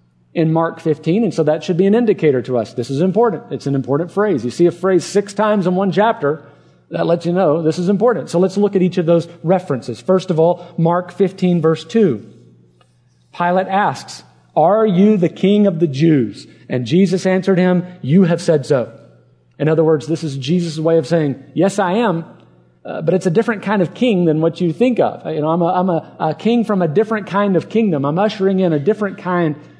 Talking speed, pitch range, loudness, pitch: 225 wpm, 155-195 Hz, -16 LUFS, 175 Hz